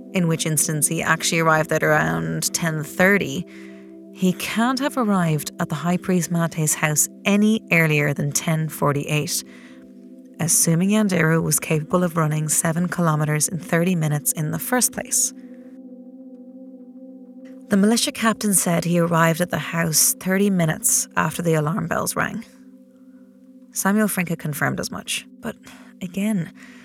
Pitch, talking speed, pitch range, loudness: 175 Hz, 145 wpm, 155-235 Hz, -20 LUFS